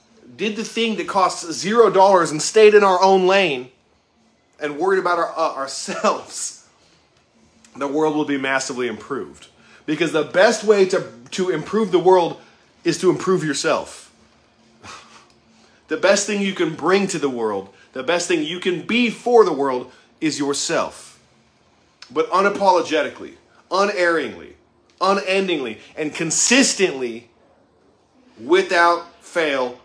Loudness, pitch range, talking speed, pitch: -19 LUFS, 155-195 Hz, 135 wpm, 175 Hz